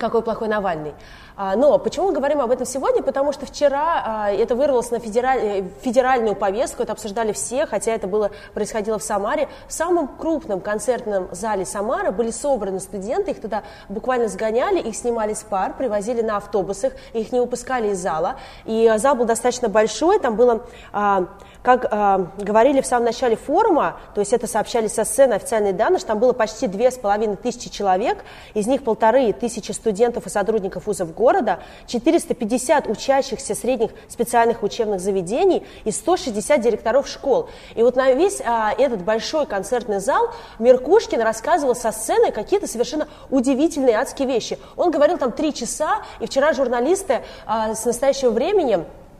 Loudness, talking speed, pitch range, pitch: -20 LUFS, 165 wpm, 215-275 Hz, 235 Hz